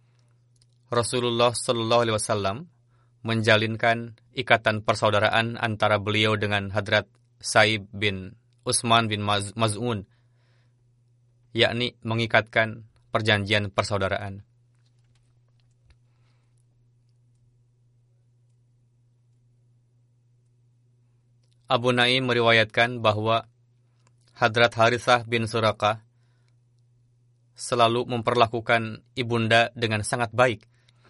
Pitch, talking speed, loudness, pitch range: 120 Hz, 65 wpm, -23 LUFS, 115-120 Hz